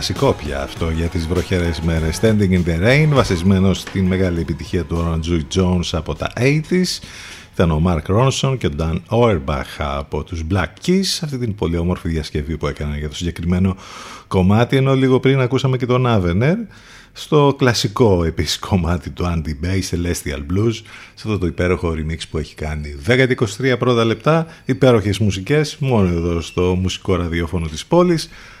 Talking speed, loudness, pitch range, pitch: 170 wpm, -18 LUFS, 85-125 Hz, 95 Hz